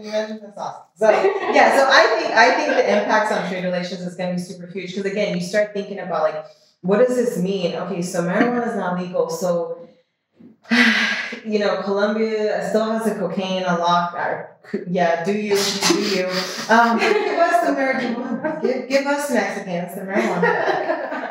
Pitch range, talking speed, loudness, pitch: 180-230 Hz, 175 wpm, -19 LUFS, 205 Hz